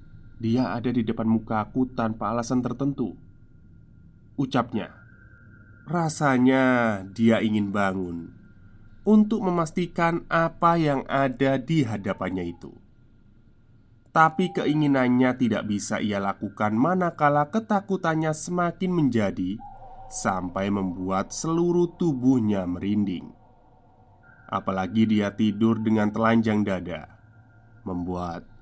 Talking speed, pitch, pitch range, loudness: 90 wpm, 115 Hz, 105-140 Hz, -24 LUFS